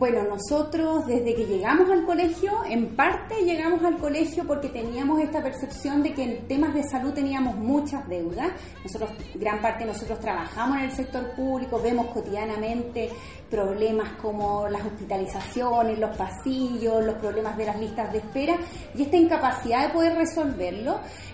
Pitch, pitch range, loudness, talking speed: 250 Hz, 220-300 Hz, -26 LUFS, 155 wpm